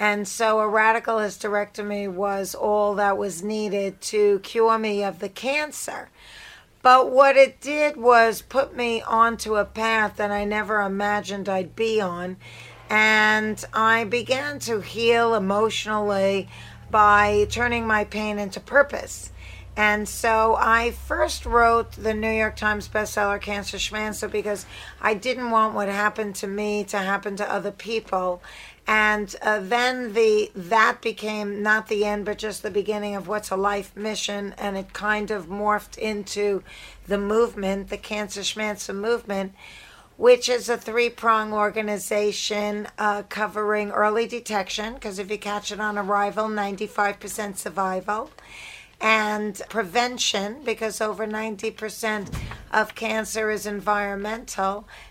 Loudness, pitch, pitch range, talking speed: -23 LUFS, 210 Hz, 205-220 Hz, 140 wpm